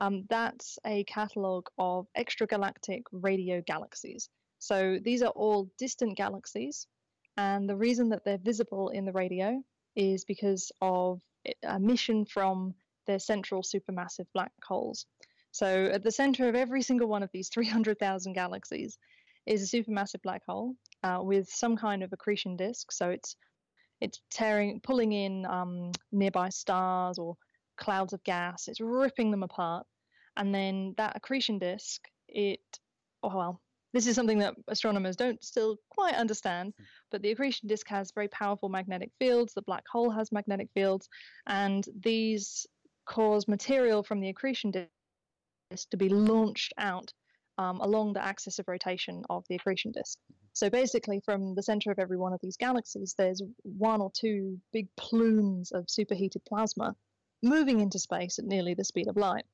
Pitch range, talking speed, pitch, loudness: 190-225 Hz, 160 wpm, 200 Hz, -32 LUFS